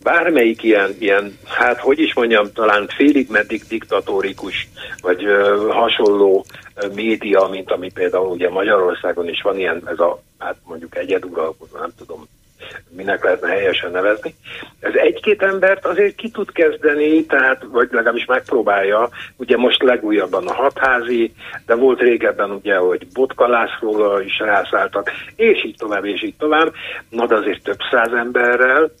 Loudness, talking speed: -16 LUFS, 140 wpm